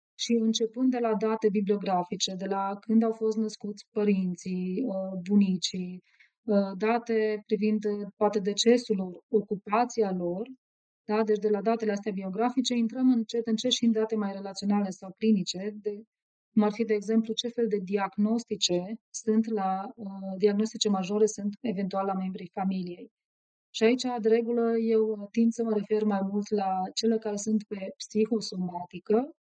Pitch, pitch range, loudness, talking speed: 215 Hz, 195-225 Hz, -28 LUFS, 150 wpm